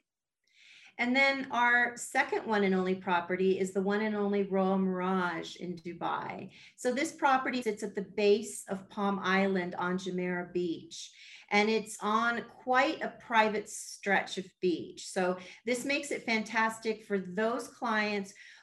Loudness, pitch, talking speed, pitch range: -31 LUFS, 210 Hz, 150 wpm, 190-240 Hz